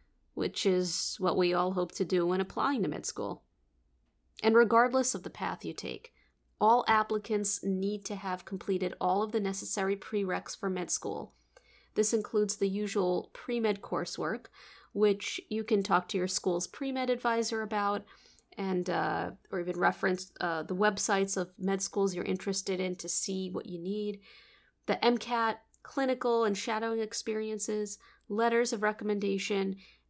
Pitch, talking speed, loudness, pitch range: 200 Hz, 155 wpm, -31 LUFS, 185-220 Hz